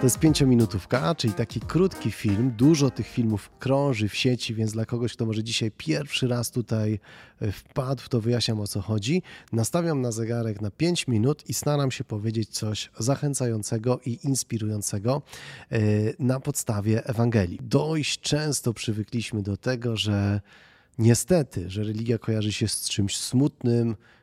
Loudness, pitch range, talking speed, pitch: -26 LUFS, 110-135 Hz, 145 wpm, 120 Hz